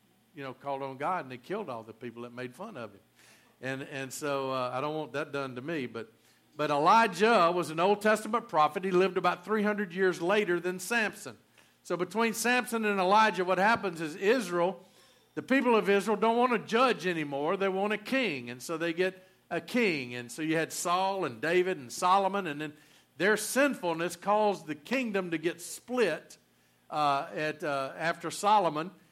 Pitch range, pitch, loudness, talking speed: 150-210 Hz, 175 Hz, -29 LUFS, 195 wpm